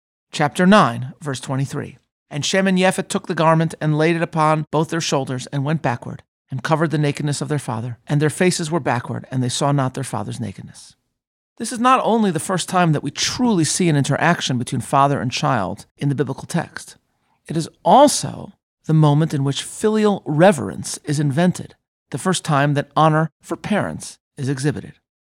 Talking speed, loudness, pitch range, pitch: 195 wpm, -19 LUFS, 140-170 Hz, 150 Hz